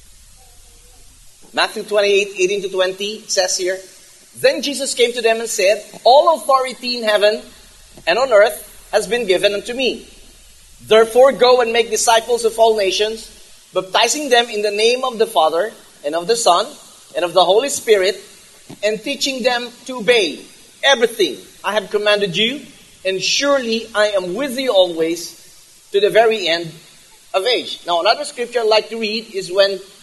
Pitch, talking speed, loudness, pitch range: 215 Hz, 165 wpm, -16 LUFS, 190-245 Hz